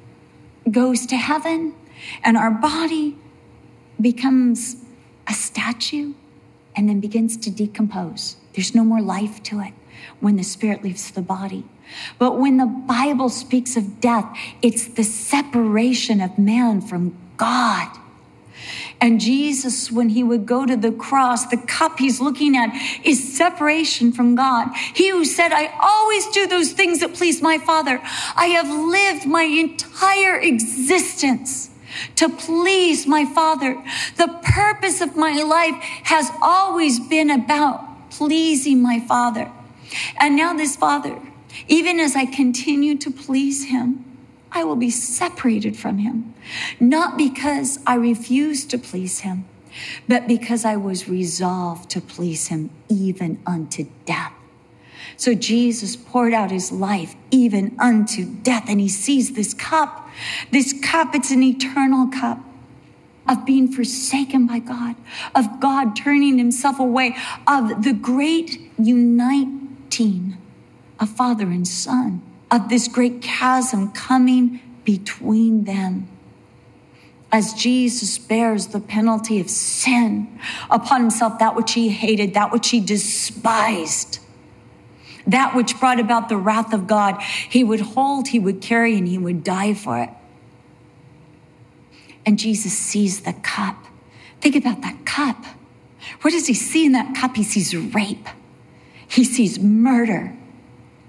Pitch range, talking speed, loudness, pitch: 220-280 Hz, 135 wpm, -19 LUFS, 245 Hz